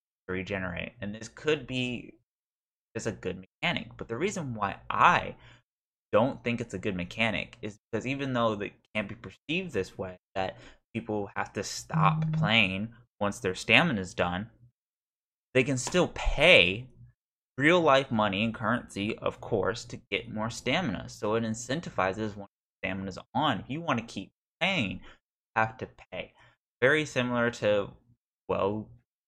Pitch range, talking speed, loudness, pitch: 95-120 Hz, 160 wpm, -29 LUFS, 110 Hz